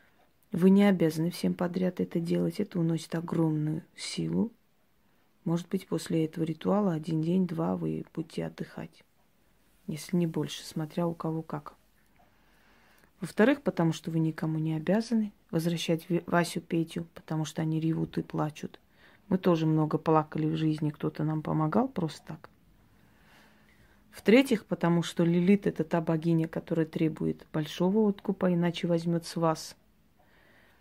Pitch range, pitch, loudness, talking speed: 160-180 Hz, 170 Hz, -29 LUFS, 135 wpm